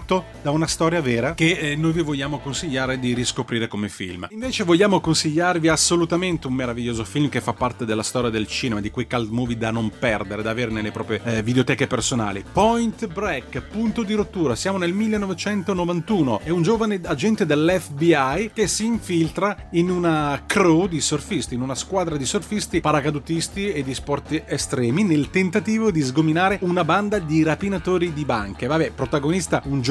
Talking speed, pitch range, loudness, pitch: 175 wpm, 125-185 Hz, -22 LUFS, 160 Hz